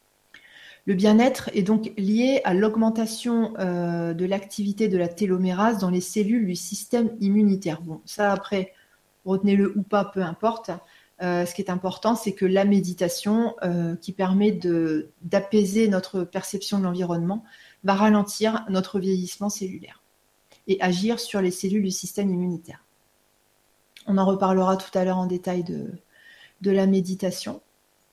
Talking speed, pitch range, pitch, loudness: 150 wpm, 180-210 Hz, 195 Hz, -24 LUFS